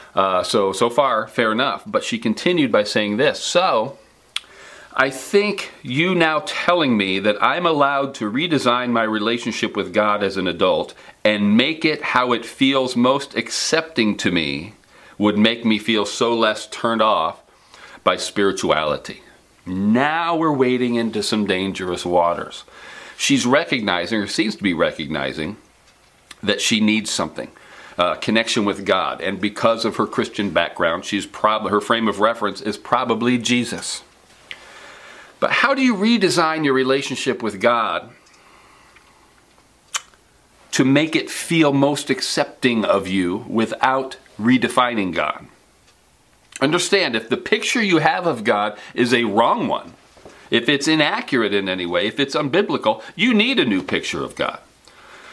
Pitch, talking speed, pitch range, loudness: 120 Hz, 145 wpm, 105-150 Hz, -19 LUFS